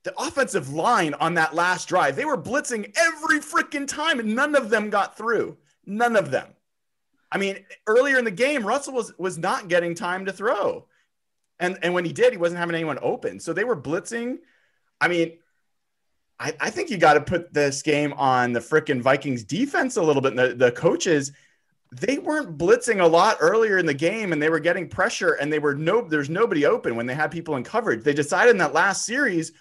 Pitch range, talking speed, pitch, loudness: 155-245 Hz, 215 wpm, 180 Hz, -22 LUFS